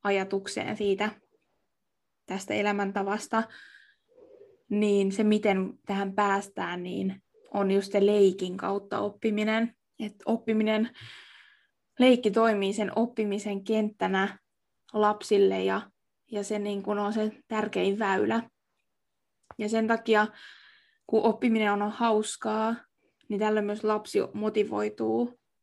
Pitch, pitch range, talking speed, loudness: 210 Hz, 200-225 Hz, 105 wpm, -28 LUFS